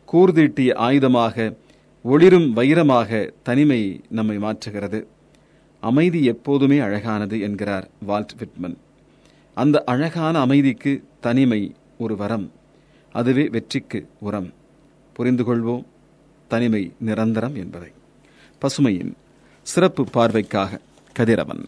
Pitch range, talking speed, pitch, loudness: 105-140 Hz, 85 wpm, 120 Hz, -20 LUFS